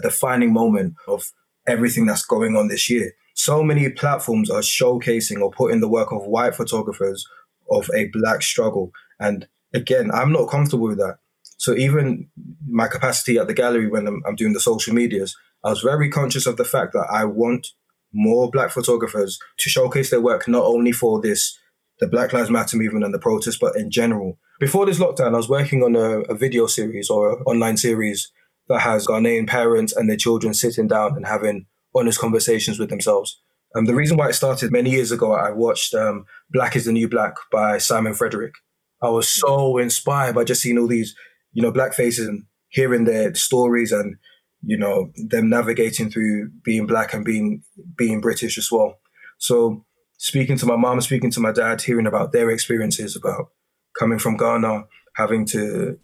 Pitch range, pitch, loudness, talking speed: 110-140 Hz, 120 Hz, -19 LUFS, 190 wpm